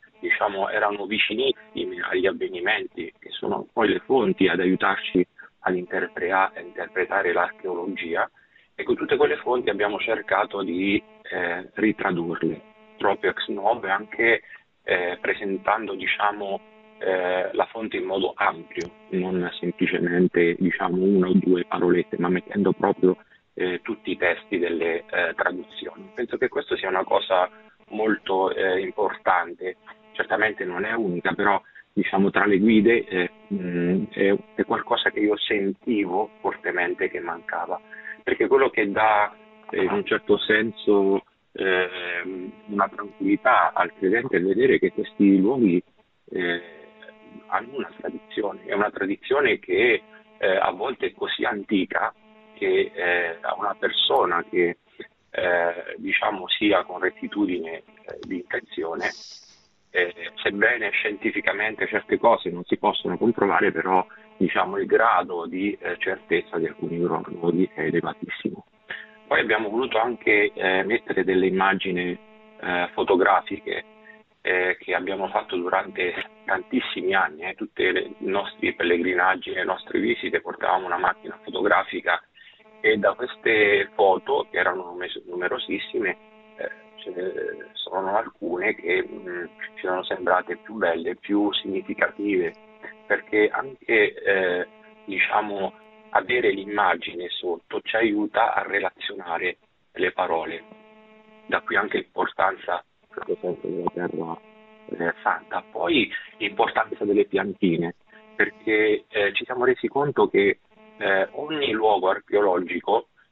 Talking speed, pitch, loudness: 125 wpm, 215 Hz, -24 LUFS